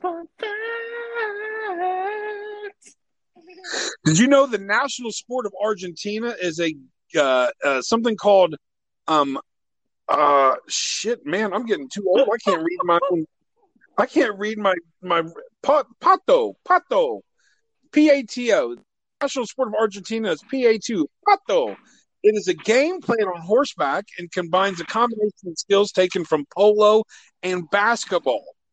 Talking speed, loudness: 125 wpm, -21 LUFS